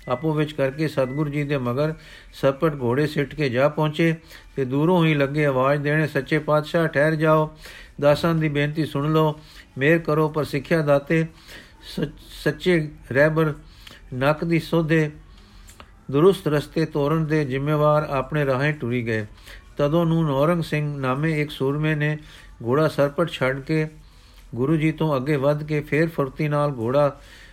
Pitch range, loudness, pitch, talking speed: 140-155 Hz, -22 LUFS, 150 Hz, 150 wpm